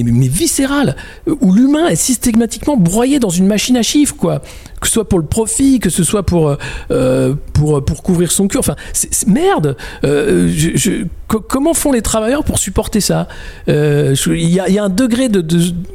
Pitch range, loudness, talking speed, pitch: 160-255 Hz, -13 LUFS, 205 wpm, 195 Hz